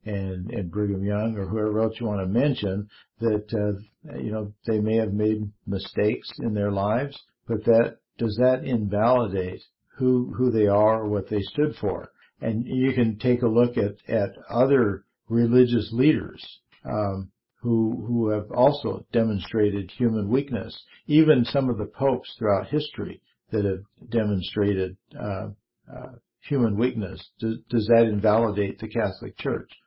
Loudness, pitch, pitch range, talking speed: -24 LUFS, 110 Hz, 105-120 Hz, 155 wpm